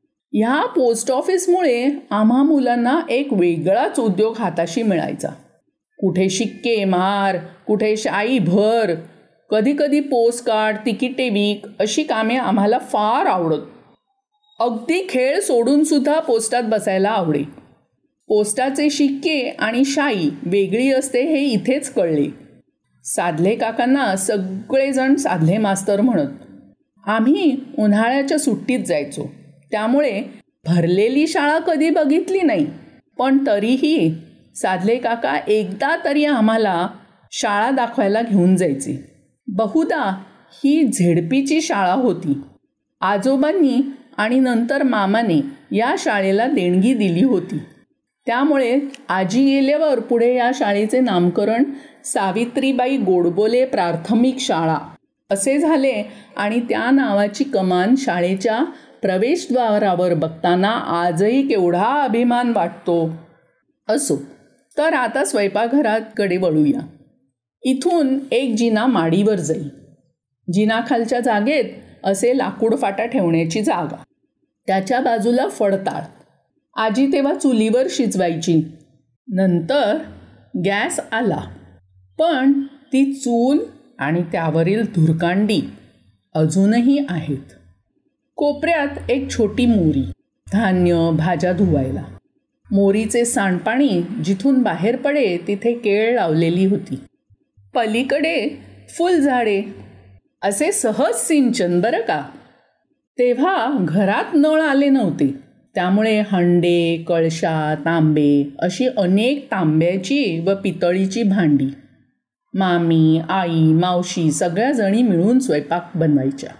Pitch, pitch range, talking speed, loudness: 220 Hz, 180-270 Hz, 95 wpm, -18 LUFS